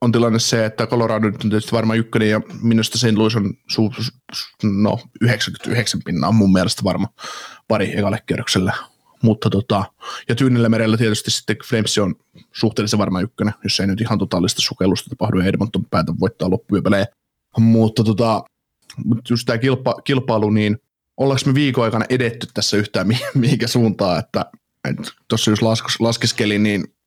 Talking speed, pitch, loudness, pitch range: 165 wpm, 110 Hz, -18 LUFS, 105-120 Hz